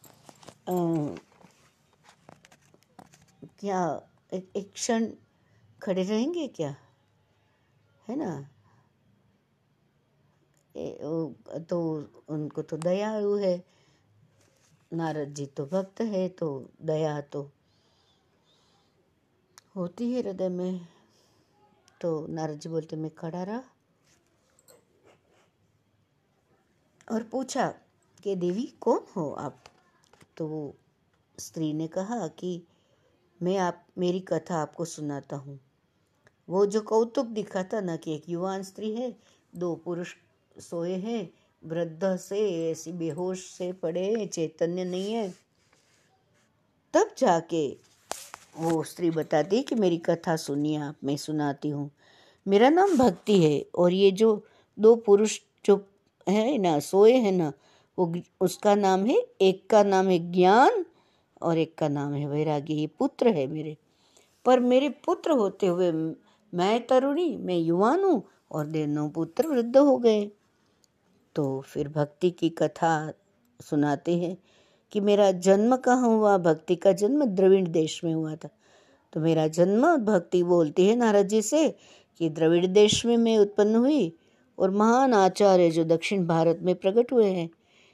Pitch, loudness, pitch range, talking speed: 180 Hz, -26 LUFS, 155-210 Hz, 130 wpm